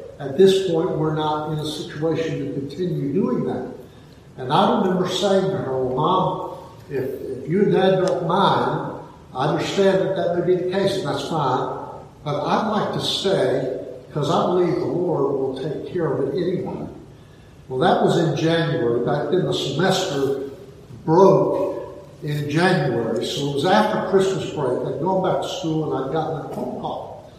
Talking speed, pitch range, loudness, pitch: 180 wpm, 150-190 Hz, -21 LUFS, 180 Hz